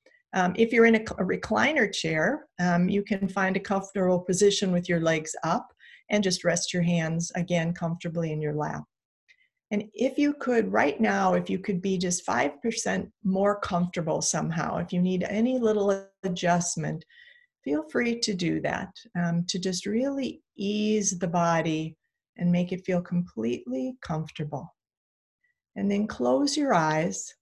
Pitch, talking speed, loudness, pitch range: 190 Hz, 160 wpm, -27 LUFS, 175-215 Hz